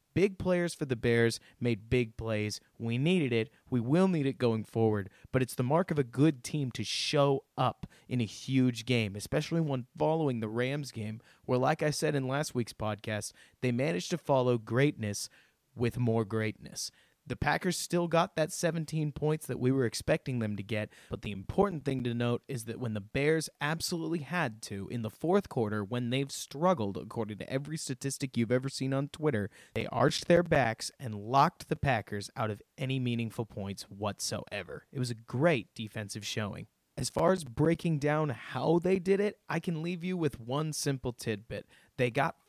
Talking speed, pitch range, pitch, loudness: 195 wpm, 115-155 Hz, 130 Hz, -32 LUFS